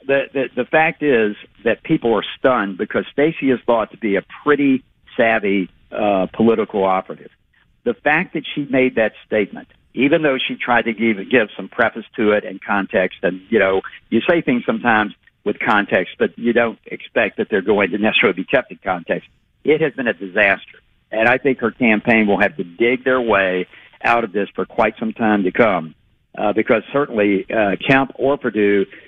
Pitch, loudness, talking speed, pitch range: 115 Hz, -18 LUFS, 195 wpm, 100-135 Hz